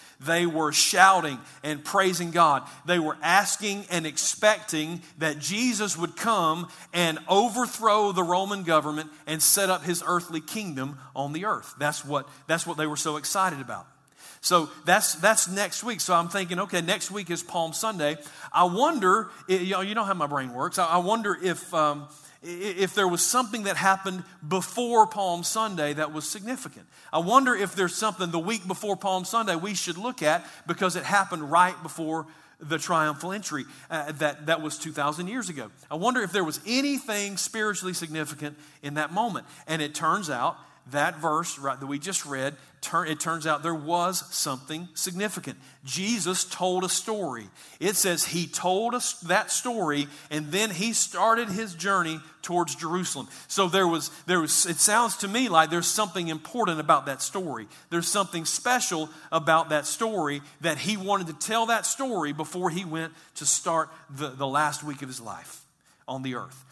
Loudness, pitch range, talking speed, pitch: -25 LUFS, 155-200 Hz, 180 wpm, 175 Hz